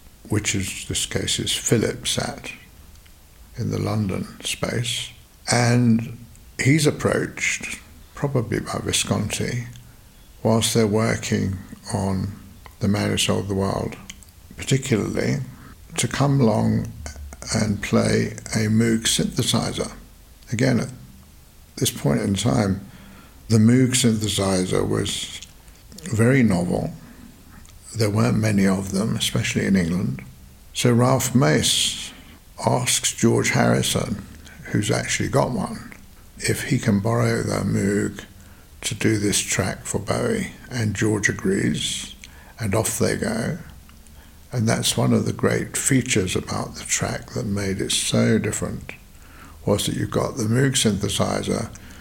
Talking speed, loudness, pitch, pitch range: 125 wpm, -22 LUFS, 105 Hz, 95-115 Hz